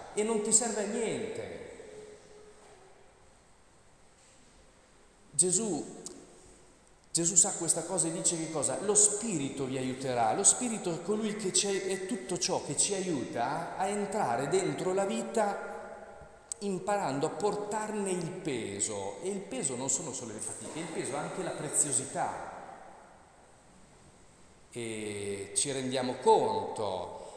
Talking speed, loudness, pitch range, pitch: 130 wpm, -30 LUFS, 160-215 Hz, 195 Hz